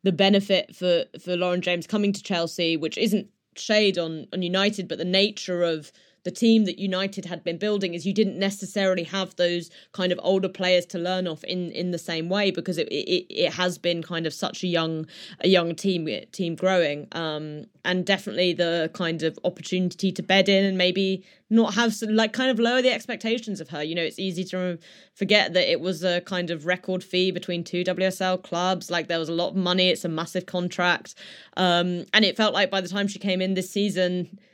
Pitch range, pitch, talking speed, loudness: 175-195 Hz, 185 Hz, 215 wpm, -24 LUFS